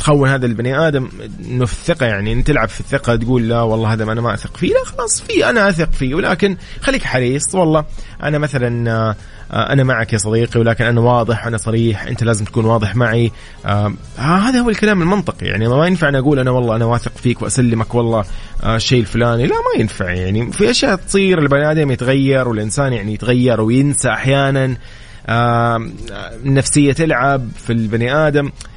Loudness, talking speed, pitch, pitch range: -15 LUFS, 185 wpm, 120 Hz, 115-140 Hz